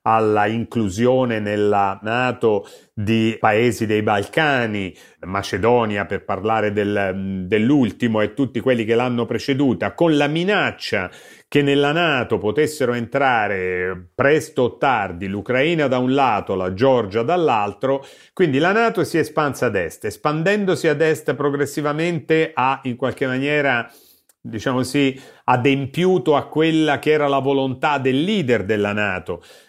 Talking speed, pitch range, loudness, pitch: 135 wpm, 110-145 Hz, -19 LUFS, 130 Hz